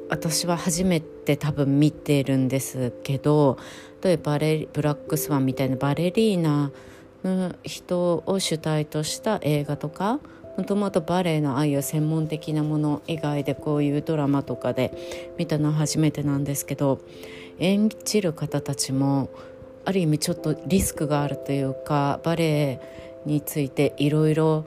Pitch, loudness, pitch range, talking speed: 150 Hz, -24 LUFS, 140-170 Hz, 305 characters per minute